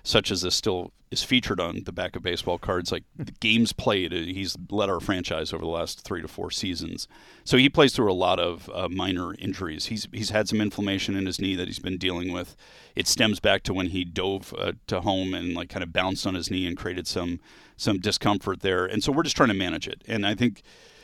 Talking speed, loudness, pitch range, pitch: 240 wpm, -26 LUFS, 90-110 Hz, 95 Hz